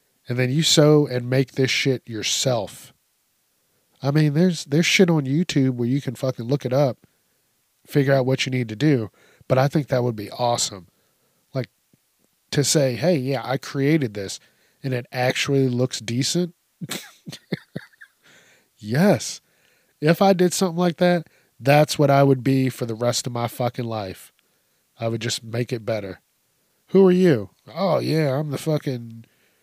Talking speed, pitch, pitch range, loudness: 170 wpm, 135 Hz, 120-150 Hz, -21 LUFS